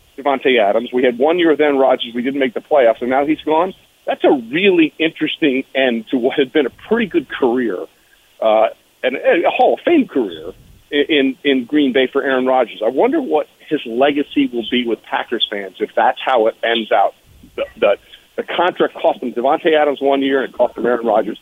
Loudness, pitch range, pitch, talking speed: -16 LUFS, 130-155 Hz, 140 Hz, 215 wpm